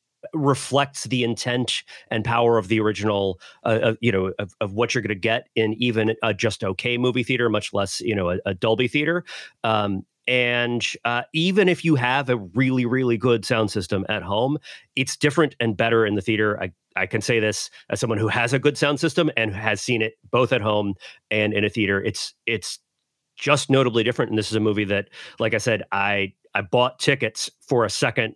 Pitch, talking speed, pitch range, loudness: 115 Hz, 210 wpm, 105-125 Hz, -22 LUFS